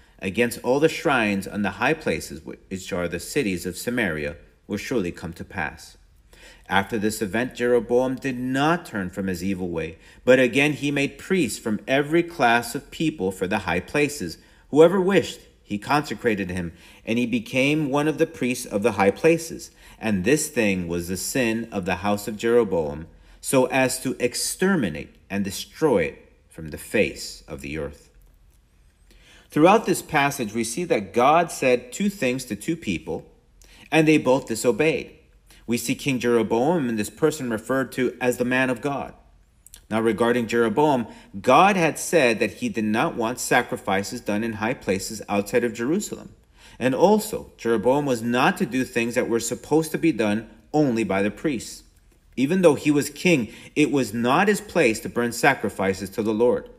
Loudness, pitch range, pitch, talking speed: -23 LUFS, 100-140 Hz, 120 Hz, 180 wpm